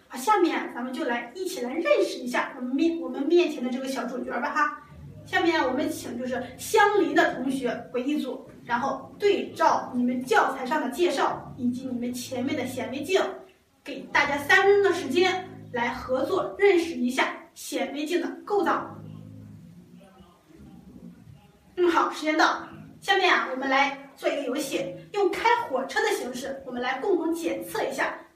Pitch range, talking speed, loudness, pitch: 255-350 Hz, 260 characters per minute, -26 LUFS, 300 Hz